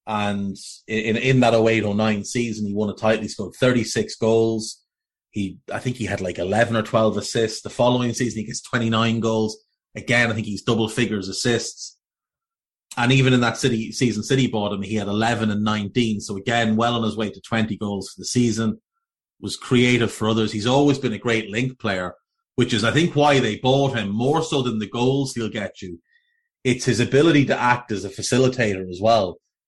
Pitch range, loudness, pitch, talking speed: 105-125 Hz, -21 LUFS, 115 Hz, 205 wpm